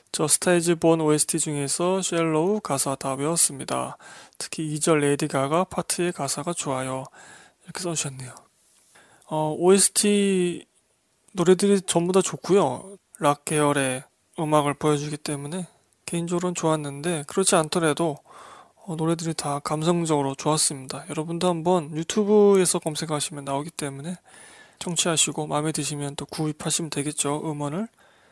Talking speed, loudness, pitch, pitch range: 325 characters per minute, -23 LUFS, 160 Hz, 145-175 Hz